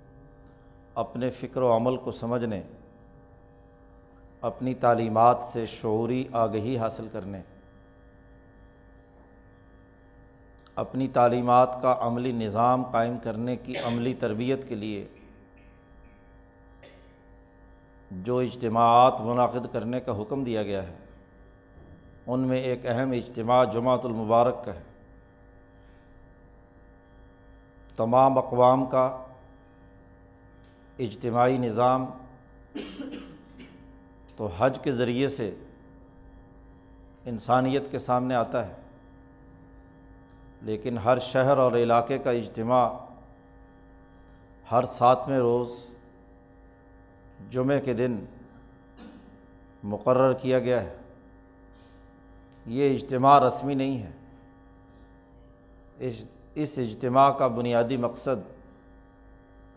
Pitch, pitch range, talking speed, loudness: 115 Hz, 95-125 Hz, 85 wpm, -25 LUFS